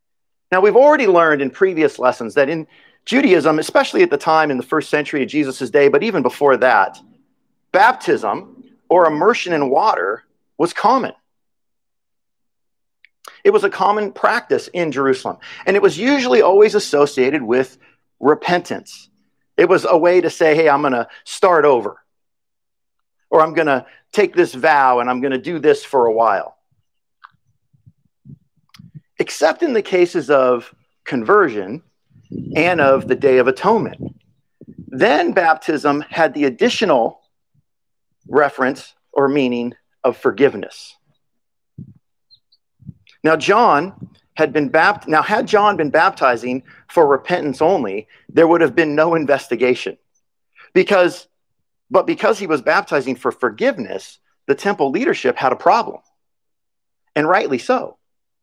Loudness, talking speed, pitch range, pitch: -16 LUFS, 135 wpm, 140-210 Hz, 160 Hz